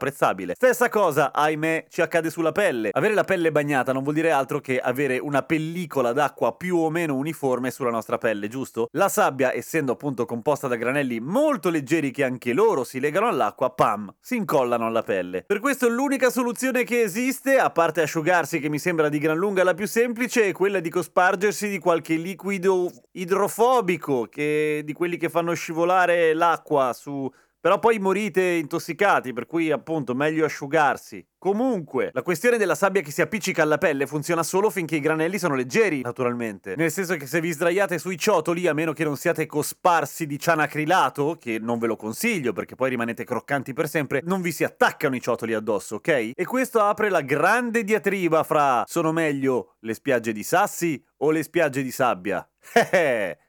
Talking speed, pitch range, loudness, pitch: 185 wpm, 140-190 Hz, -23 LUFS, 165 Hz